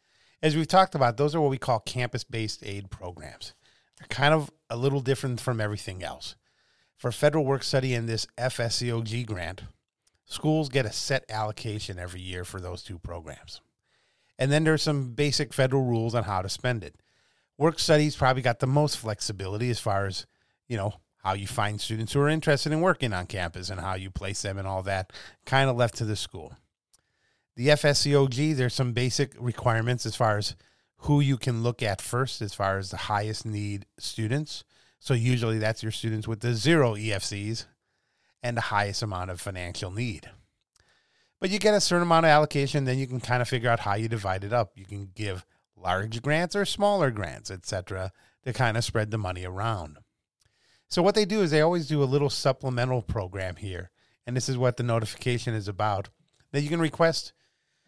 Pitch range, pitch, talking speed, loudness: 100-135 Hz, 115 Hz, 195 wpm, -27 LUFS